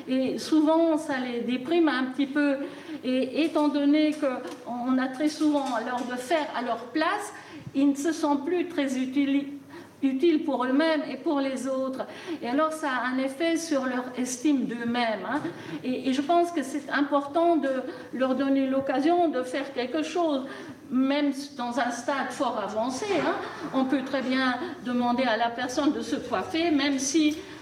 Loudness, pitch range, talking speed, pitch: -27 LUFS, 260-310 Hz, 170 wpm, 280 Hz